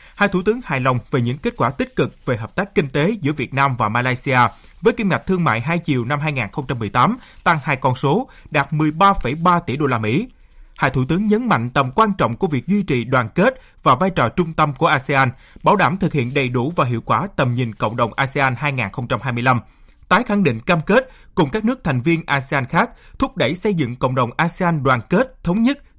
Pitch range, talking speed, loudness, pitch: 130-185 Hz, 230 wpm, -19 LUFS, 145 Hz